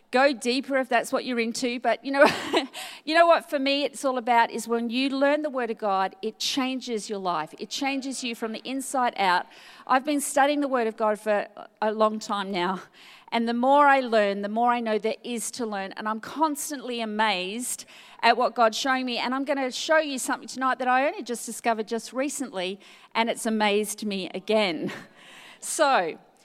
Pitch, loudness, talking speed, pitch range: 240 Hz, -25 LUFS, 210 wpm, 220-270 Hz